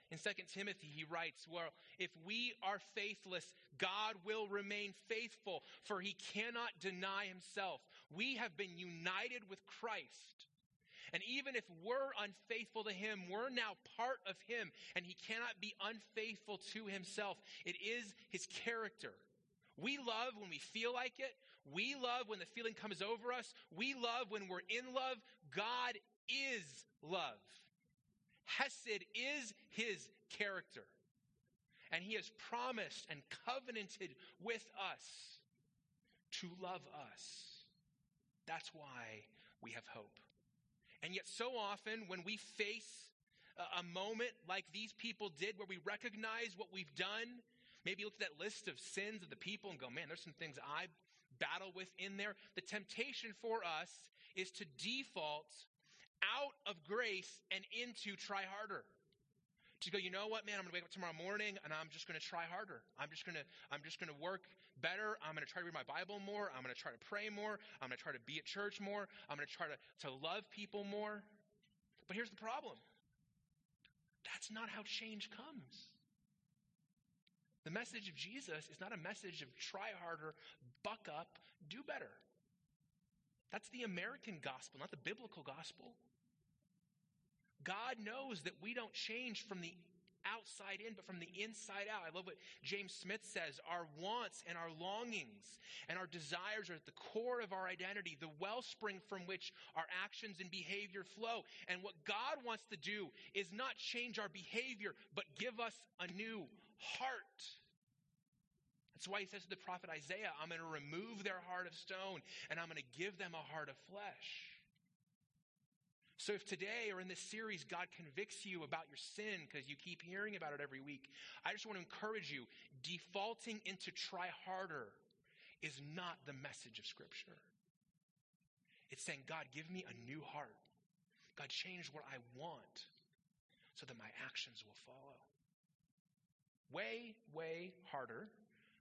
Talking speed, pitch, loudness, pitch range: 165 wpm, 195 Hz, -47 LUFS, 170-215 Hz